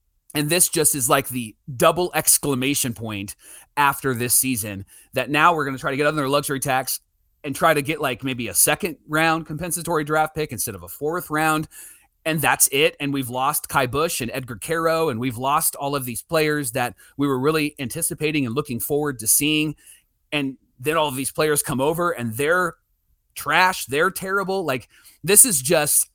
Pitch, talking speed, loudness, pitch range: 145 Hz, 195 wpm, -20 LUFS, 130-160 Hz